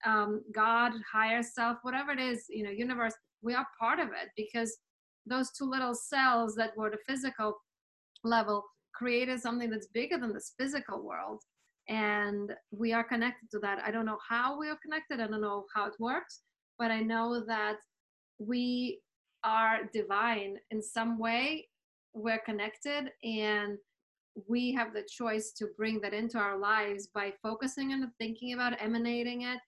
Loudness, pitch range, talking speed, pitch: -34 LUFS, 215-245 Hz, 165 wpm, 230 Hz